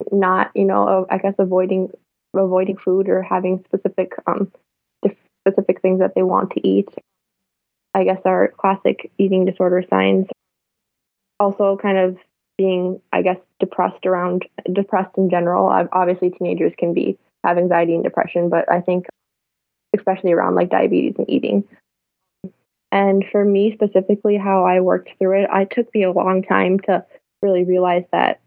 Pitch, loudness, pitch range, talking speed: 185 Hz, -18 LUFS, 180-195 Hz, 155 wpm